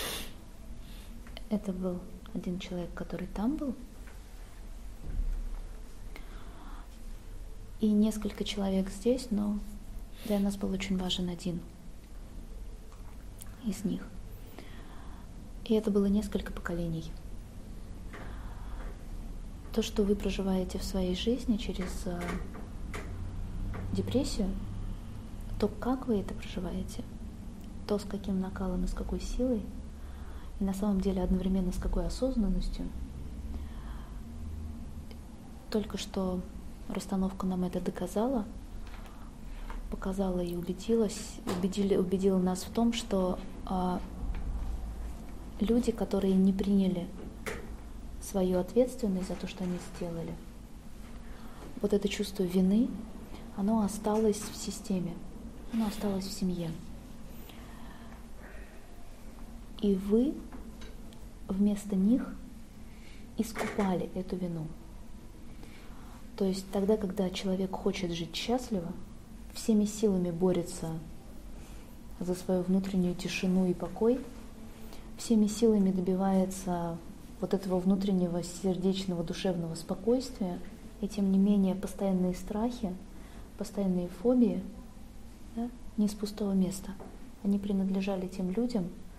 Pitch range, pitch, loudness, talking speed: 170-210 Hz, 190 Hz, -32 LUFS, 95 wpm